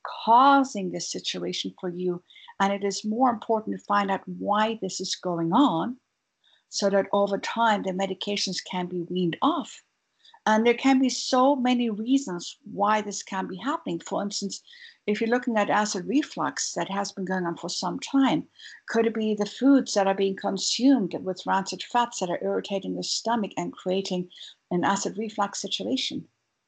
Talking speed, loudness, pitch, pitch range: 180 wpm, -26 LUFS, 200 Hz, 185-240 Hz